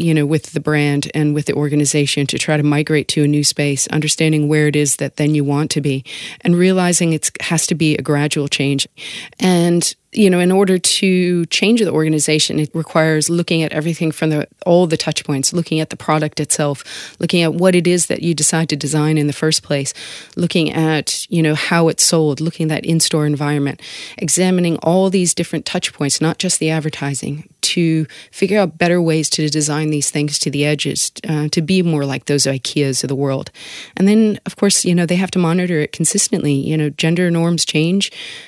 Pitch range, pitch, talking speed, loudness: 150-175 Hz, 155 Hz, 210 wpm, -16 LUFS